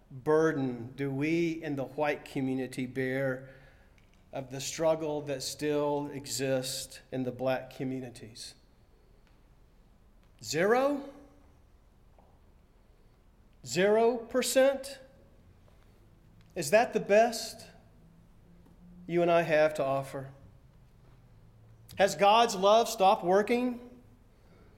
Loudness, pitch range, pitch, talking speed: -29 LUFS, 120-175 Hz, 135 Hz, 85 wpm